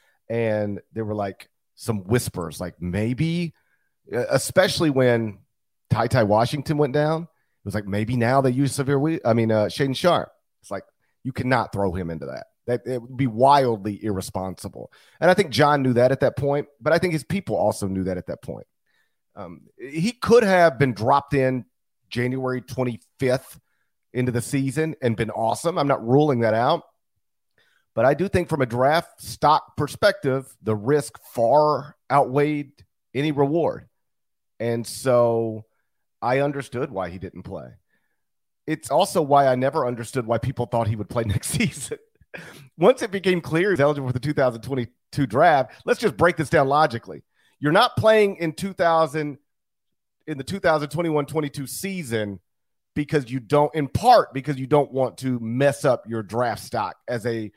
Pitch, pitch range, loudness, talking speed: 130 Hz, 115-150 Hz, -22 LUFS, 170 wpm